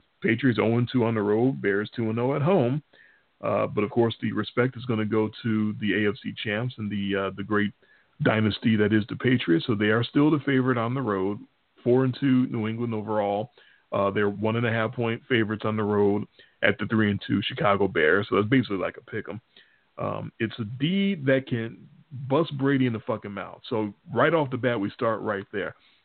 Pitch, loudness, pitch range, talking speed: 115 Hz, -25 LUFS, 105-130 Hz, 210 wpm